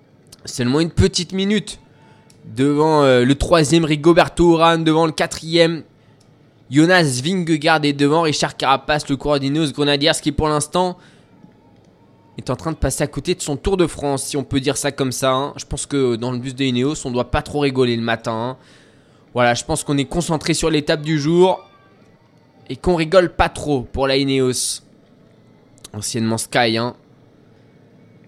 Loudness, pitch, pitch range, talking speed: -18 LUFS, 145 Hz, 130-160 Hz, 170 wpm